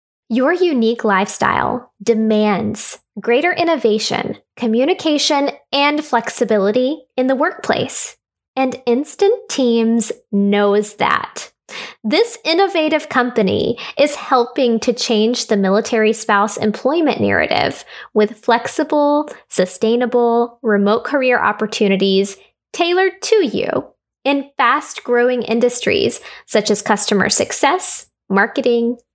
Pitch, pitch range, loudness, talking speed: 240 Hz, 215-285 Hz, -16 LUFS, 95 wpm